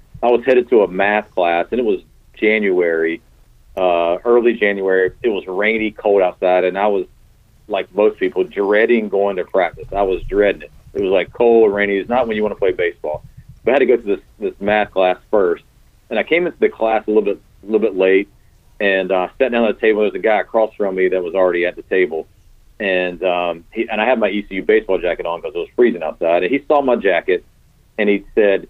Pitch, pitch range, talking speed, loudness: 105 Hz, 95-135 Hz, 245 wpm, -17 LUFS